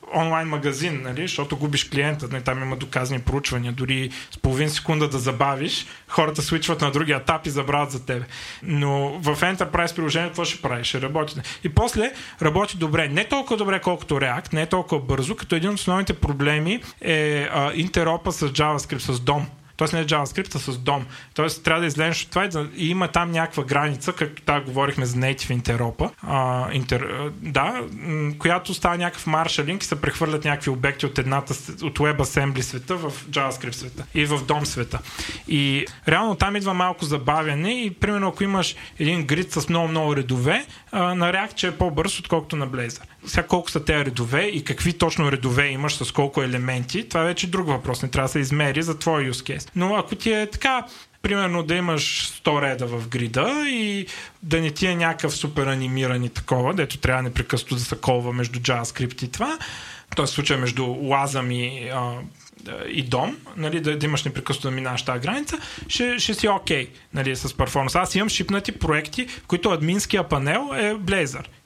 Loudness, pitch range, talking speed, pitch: -23 LUFS, 135-170 Hz, 185 wpm, 150 Hz